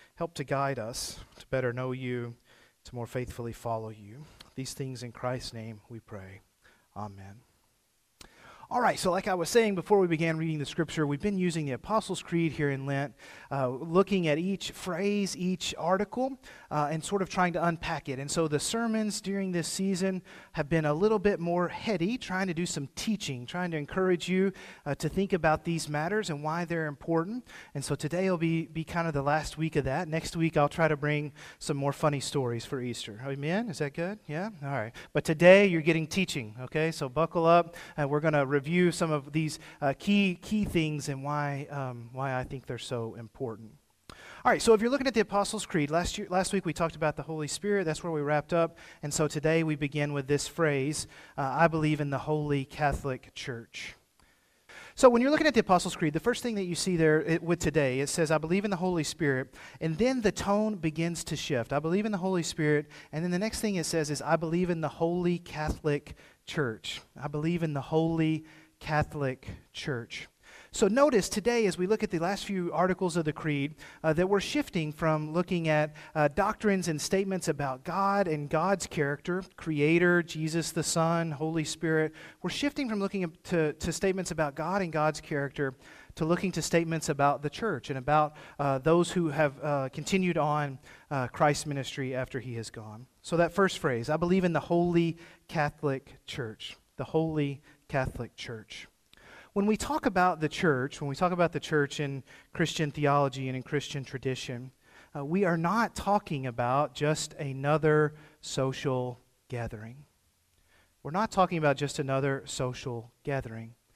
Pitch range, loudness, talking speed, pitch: 140-180 Hz, -30 LUFS, 200 wpm, 155 Hz